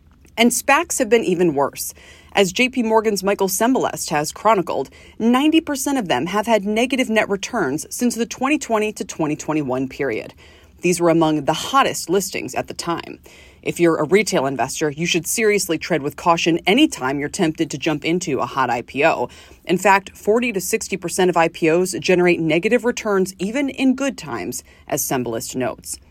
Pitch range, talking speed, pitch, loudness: 160-235 Hz, 170 wpm, 185 Hz, -19 LUFS